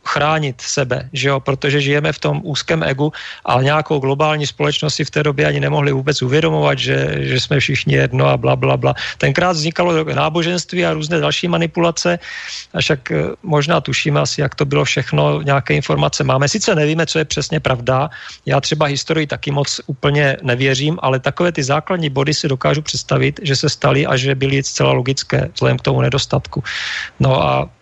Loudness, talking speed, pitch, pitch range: -16 LUFS, 185 wpm, 145 Hz, 130-155 Hz